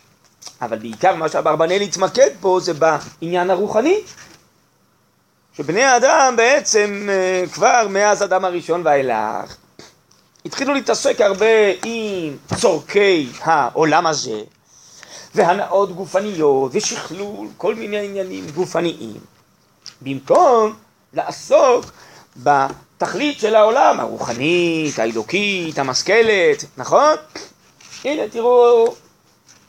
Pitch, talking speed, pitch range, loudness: 195 Hz, 85 wpm, 165-230 Hz, -17 LUFS